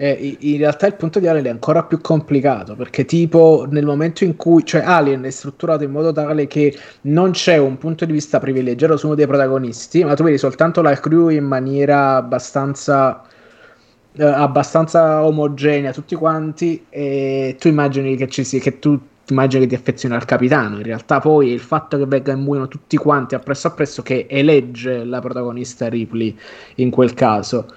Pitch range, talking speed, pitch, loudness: 130-155 Hz, 185 wpm, 140 Hz, -16 LUFS